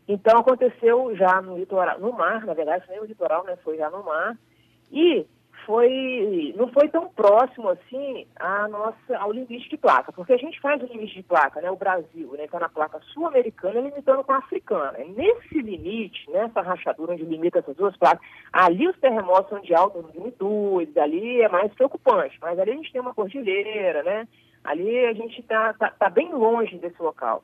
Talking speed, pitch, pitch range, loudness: 195 wpm, 225 Hz, 185-275 Hz, -23 LUFS